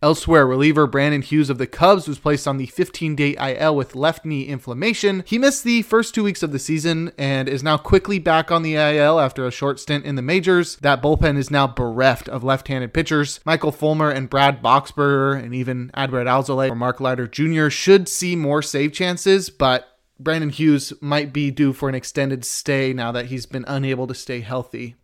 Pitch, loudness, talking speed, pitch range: 145 Hz, -19 LUFS, 205 wpm, 135-160 Hz